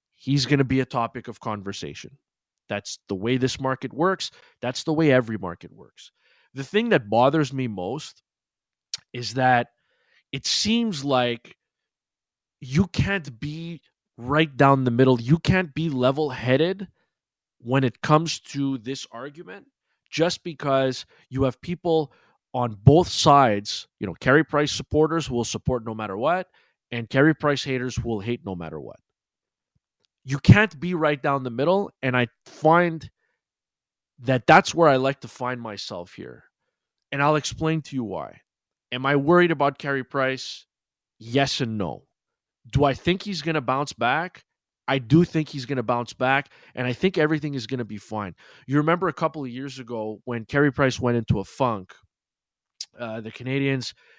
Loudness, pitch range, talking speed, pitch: -23 LUFS, 120-155 Hz, 165 wpm, 135 Hz